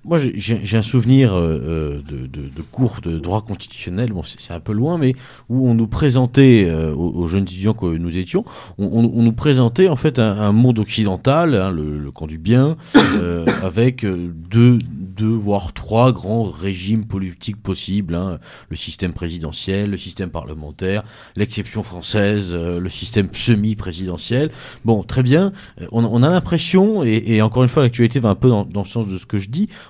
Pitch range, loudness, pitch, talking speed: 90-120 Hz, -18 LUFS, 105 Hz, 195 wpm